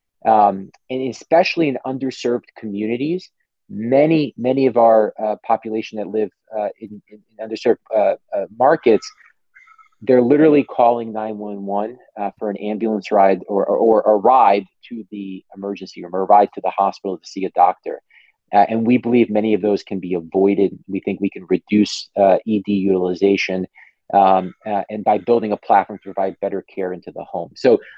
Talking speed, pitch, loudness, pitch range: 180 wpm, 105 Hz, -18 LUFS, 100-120 Hz